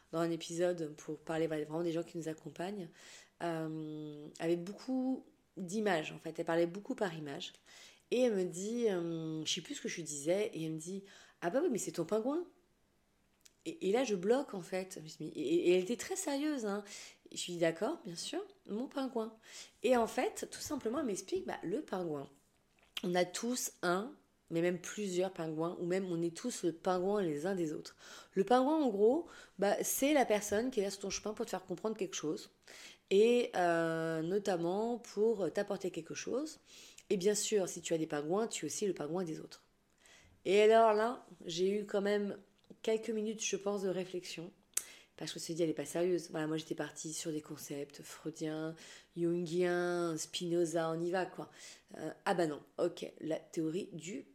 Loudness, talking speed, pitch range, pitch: -36 LUFS, 200 wpm, 165-220 Hz, 185 Hz